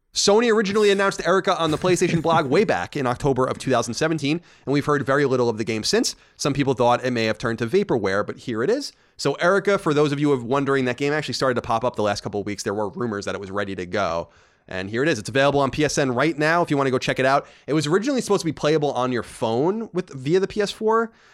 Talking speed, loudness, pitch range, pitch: 275 wpm, -22 LUFS, 125-170 Hz, 140 Hz